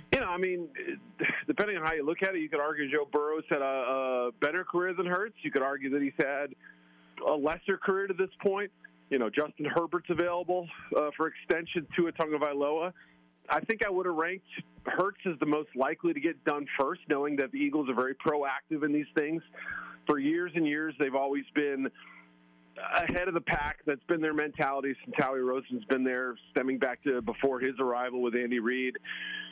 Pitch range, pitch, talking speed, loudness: 135-175 Hz, 150 Hz, 205 wpm, -31 LUFS